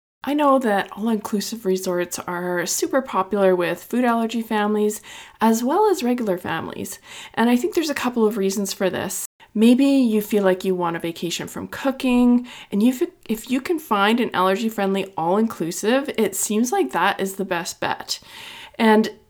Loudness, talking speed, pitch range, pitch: -21 LUFS, 175 wpm, 190-245 Hz, 215 Hz